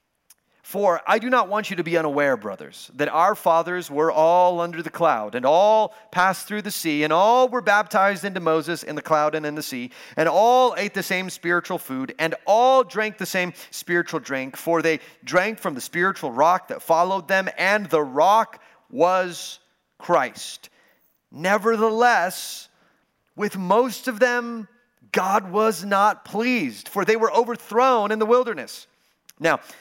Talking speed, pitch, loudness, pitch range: 165 wpm, 190 Hz, -21 LUFS, 165-220 Hz